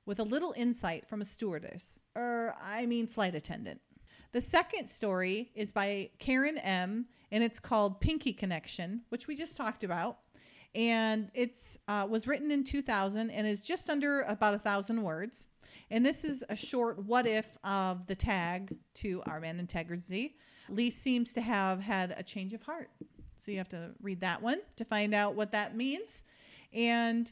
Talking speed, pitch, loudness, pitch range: 180 wpm, 220 Hz, -34 LUFS, 200-240 Hz